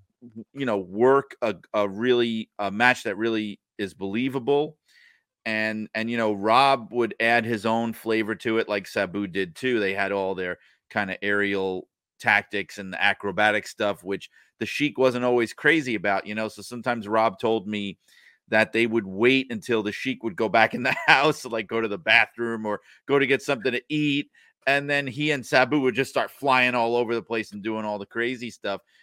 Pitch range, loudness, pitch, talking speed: 105-125 Hz, -24 LUFS, 115 Hz, 205 wpm